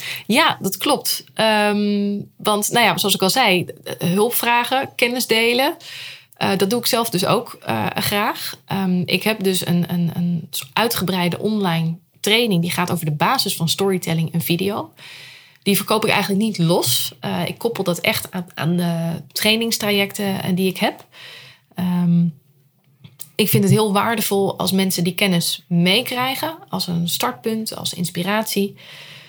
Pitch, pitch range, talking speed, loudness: 190 Hz, 170-215 Hz, 160 wpm, -19 LUFS